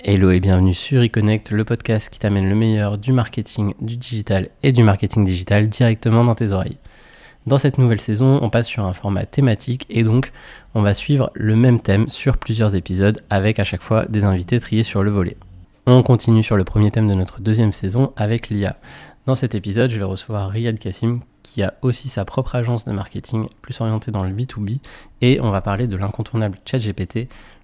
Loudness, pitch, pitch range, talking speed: -19 LUFS, 110 Hz, 100-120 Hz, 205 wpm